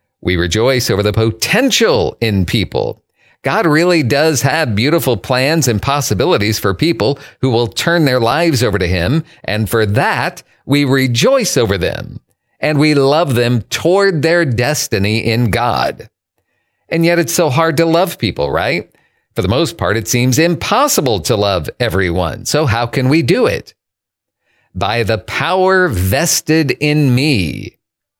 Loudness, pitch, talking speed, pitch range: -14 LUFS, 130 Hz, 155 wpm, 110-160 Hz